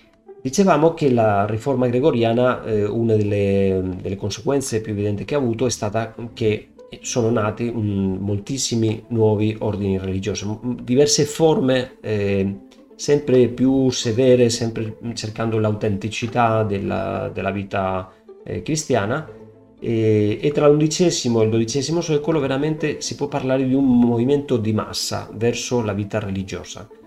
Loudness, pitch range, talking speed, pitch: -20 LUFS, 105-130 Hz, 135 wpm, 115 Hz